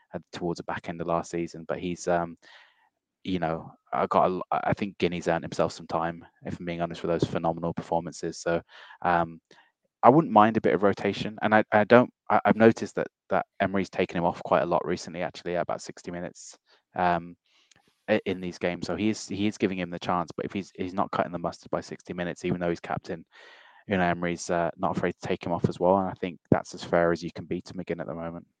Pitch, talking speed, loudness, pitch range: 85 Hz, 240 wpm, -27 LUFS, 85-95 Hz